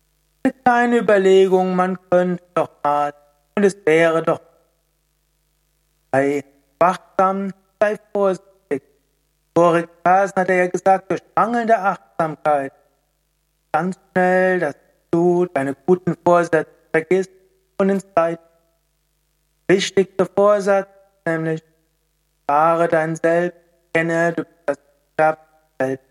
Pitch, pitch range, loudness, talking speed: 165 Hz, 160-185 Hz, -19 LUFS, 100 wpm